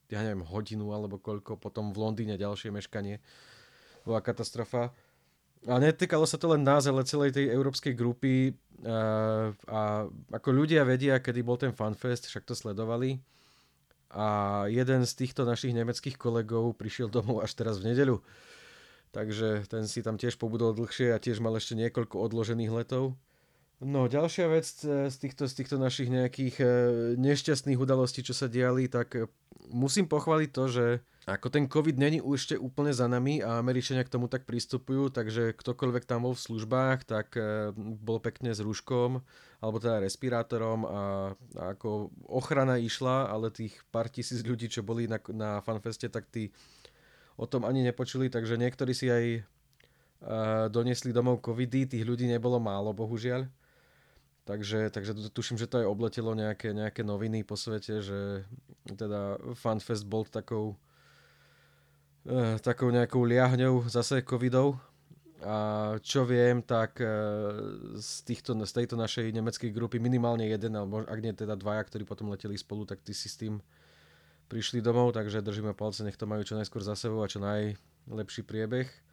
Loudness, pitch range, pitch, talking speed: -31 LUFS, 110-125 Hz, 115 Hz, 160 wpm